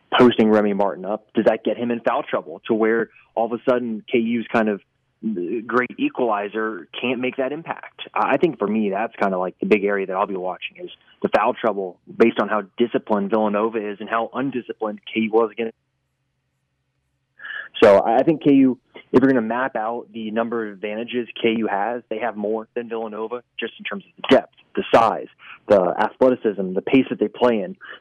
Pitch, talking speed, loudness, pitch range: 115 Hz, 200 wpm, -21 LUFS, 105-120 Hz